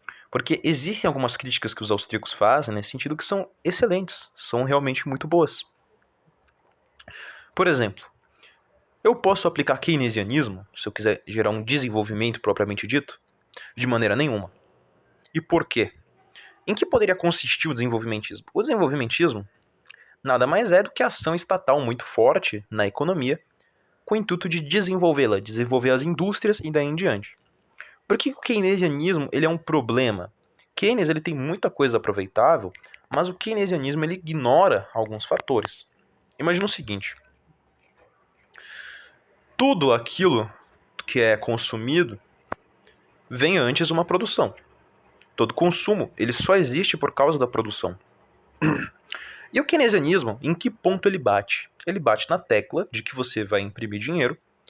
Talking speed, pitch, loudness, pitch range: 145 wpm, 145 Hz, -23 LUFS, 110-175 Hz